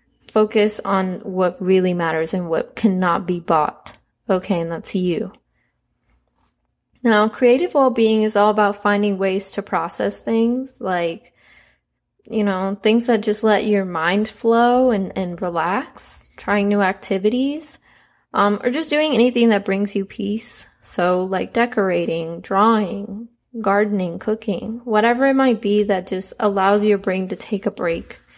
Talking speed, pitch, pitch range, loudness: 145 wpm, 205 Hz, 190-225 Hz, -19 LUFS